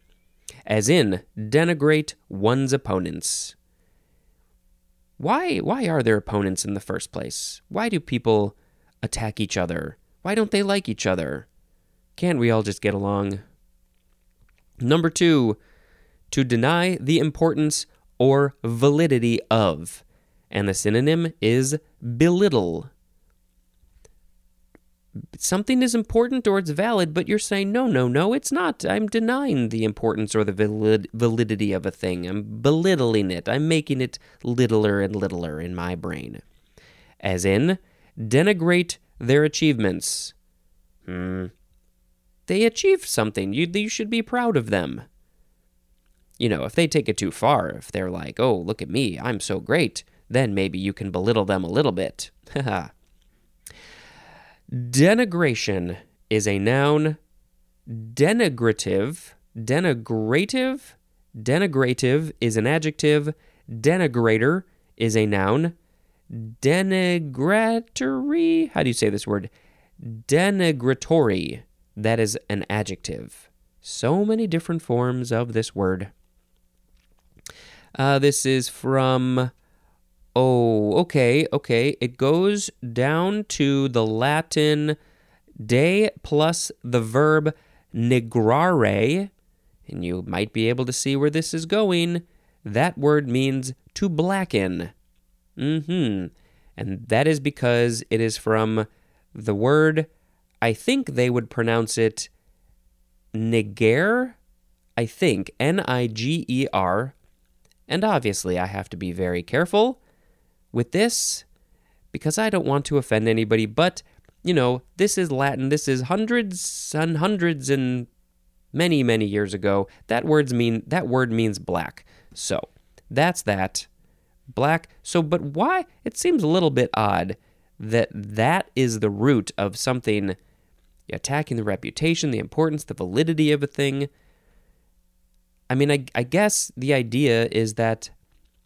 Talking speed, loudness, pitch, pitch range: 125 wpm, -22 LUFS, 125 Hz, 100-155 Hz